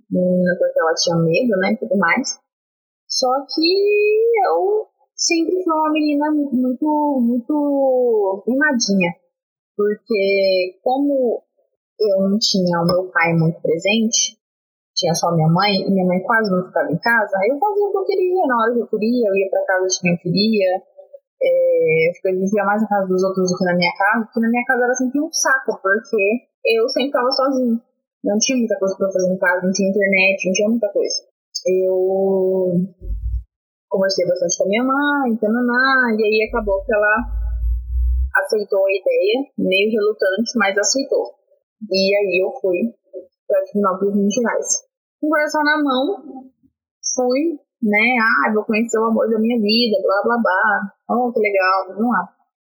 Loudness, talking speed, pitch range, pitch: -18 LUFS, 175 wpm, 190-270 Hz, 220 Hz